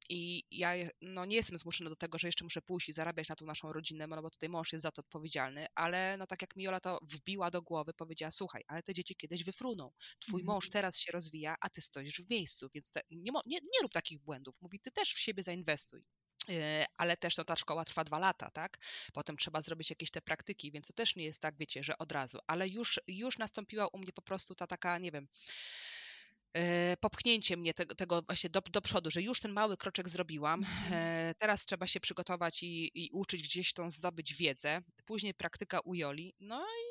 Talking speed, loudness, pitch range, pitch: 215 wpm, -36 LUFS, 160-190 Hz, 175 Hz